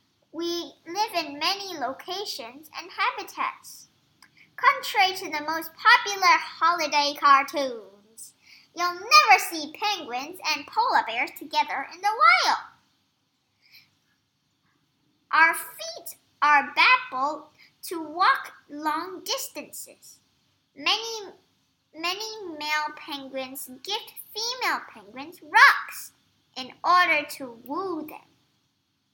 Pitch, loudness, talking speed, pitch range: 330 Hz, -23 LUFS, 95 wpm, 290-390 Hz